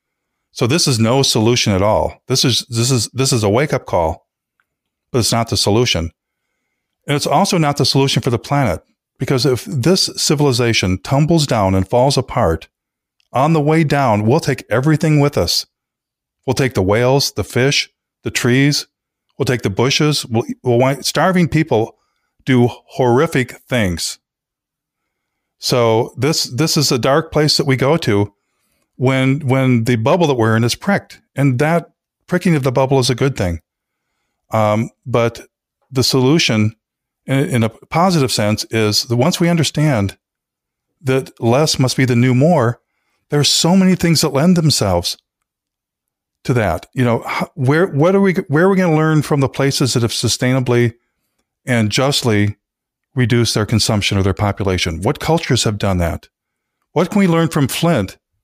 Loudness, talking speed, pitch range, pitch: -15 LUFS, 170 wpm, 115-150 Hz, 130 Hz